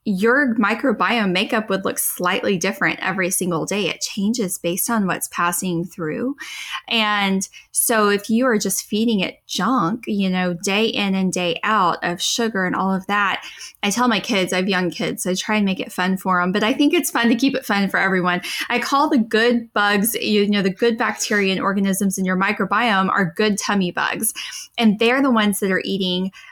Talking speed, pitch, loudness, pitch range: 210 wpm, 205 Hz, -19 LUFS, 190-230 Hz